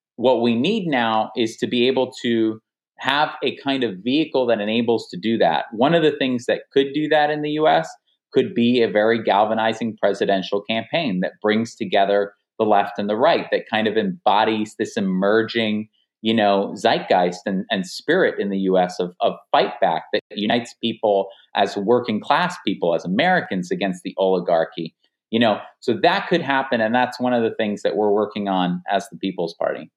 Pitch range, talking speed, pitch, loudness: 100-125 Hz, 190 wpm, 110 Hz, -20 LUFS